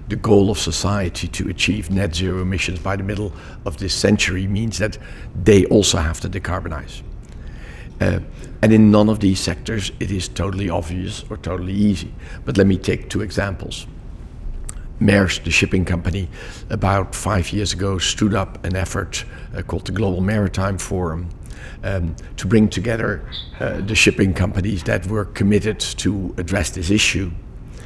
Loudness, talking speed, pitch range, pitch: -19 LUFS, 160 wpm, 90-105 Hz, 95 Hz